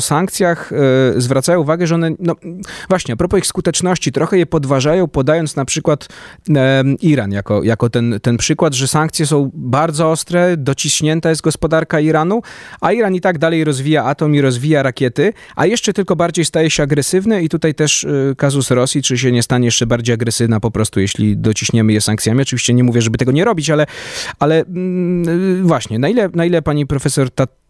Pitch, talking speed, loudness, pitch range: 150 Hz, 190 wpm, -14 LUFS, 130-170 Hz